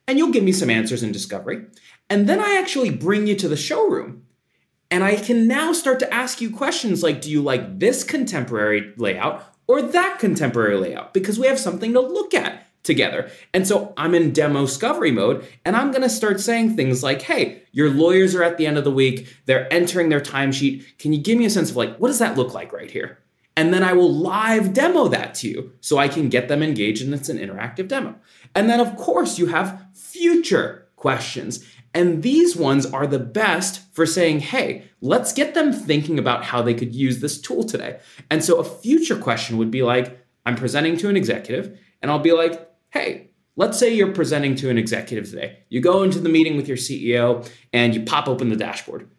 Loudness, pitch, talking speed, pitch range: -20 LUFS, 165 Hz, 215 wpm, 130-220 Hz